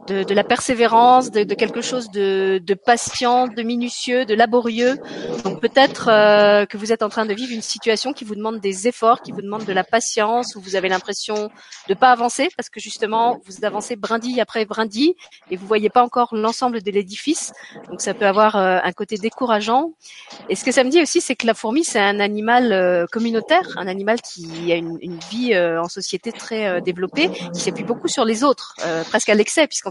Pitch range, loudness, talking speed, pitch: 200-245 Hz, -19 LUFS, 220 wpm, 220 Hz